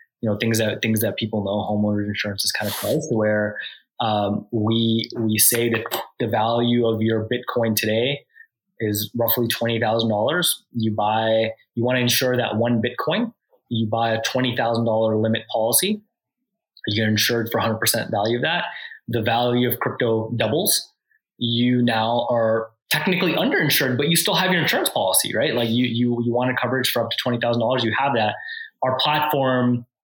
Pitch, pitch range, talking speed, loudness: 115 Hz, 110-125 Hz, 190 wpm, -21 LUFS